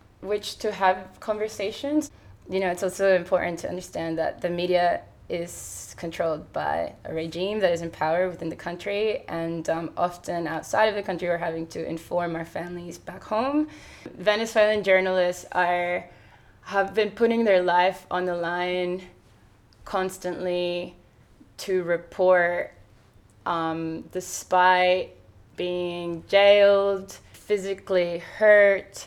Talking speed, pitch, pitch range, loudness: 125 wpm, 180 Hz, 170-195 Hz, -25 LUFS